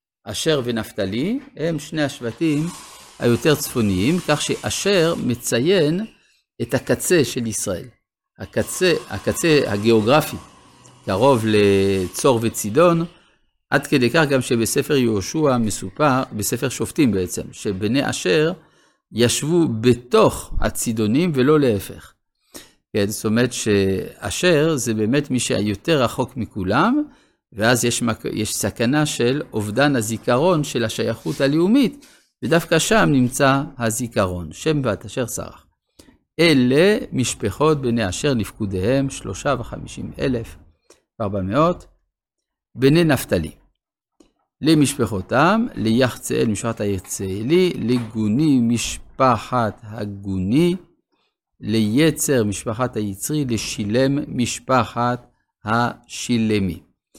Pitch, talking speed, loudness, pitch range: 125 Hz, 95 wpm, -20 LUFS, 110-150 Hz